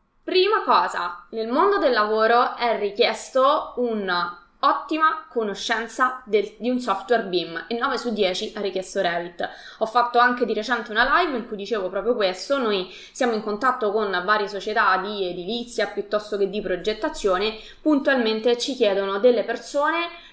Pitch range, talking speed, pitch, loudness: 200-250 Hz, 155 wpm, 225 Hz, -22 LUFS